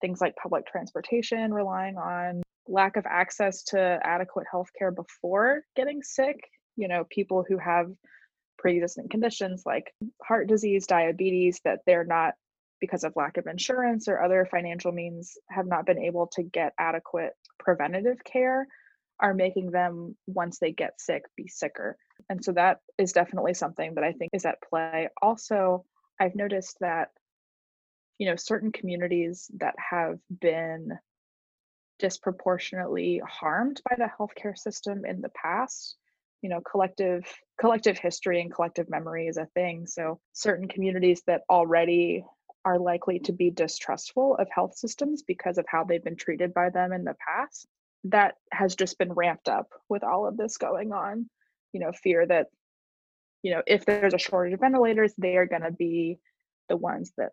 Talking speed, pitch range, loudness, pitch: 160 wpm, 175-210 Hz, -28 LUFS, 185 Hz